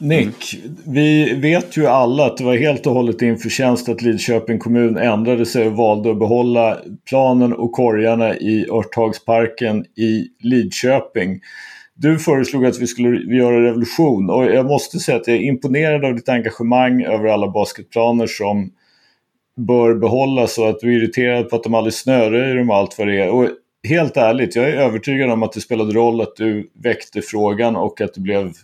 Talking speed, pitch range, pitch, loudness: 180 wpm, 110-125 Hz, 115 Hz, -16 LUFS